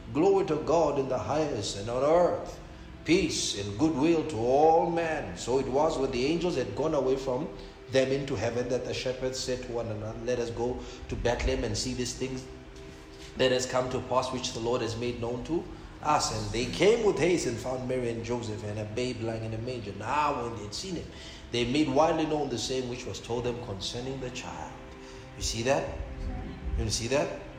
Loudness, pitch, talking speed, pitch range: -29 LUFS, 125 Hz, 215 wpm, 110-135 Hz